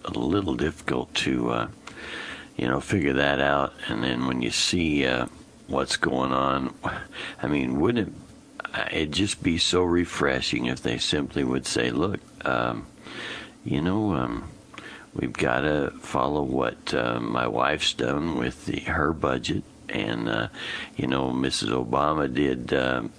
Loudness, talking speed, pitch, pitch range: -26 LUFS, 155 wpm, 65 Hz, 65-75 Hz